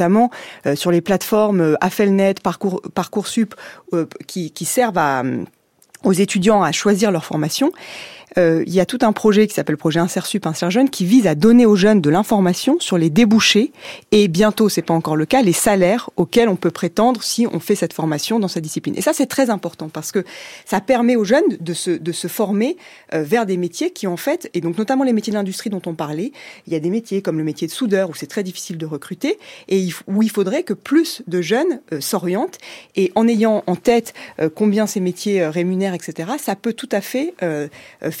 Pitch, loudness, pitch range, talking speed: 195 Hz, -18 LUFS, 175-225 Hz, 225 wpm